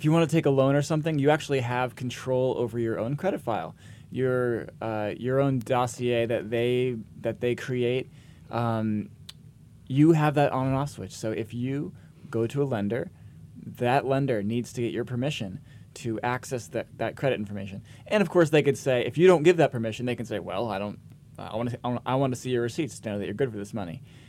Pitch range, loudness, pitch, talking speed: 115-140 Hz, -27 LUFS, 125 Hz, 225 wpm